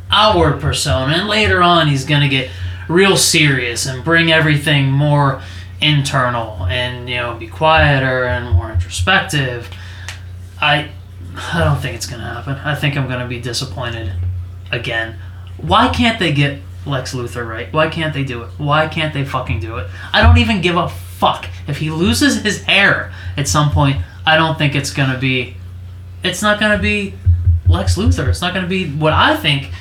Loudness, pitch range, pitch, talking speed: -15 LUFS, 90-150 Hz, 125 Hz, 175 wpm